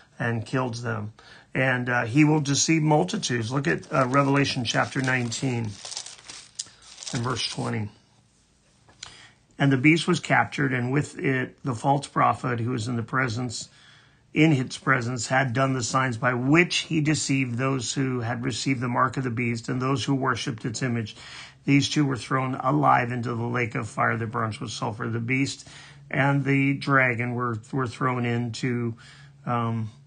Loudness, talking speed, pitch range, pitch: -25 LUFS, 170 wpm, 120-140 Hz, 130 Hz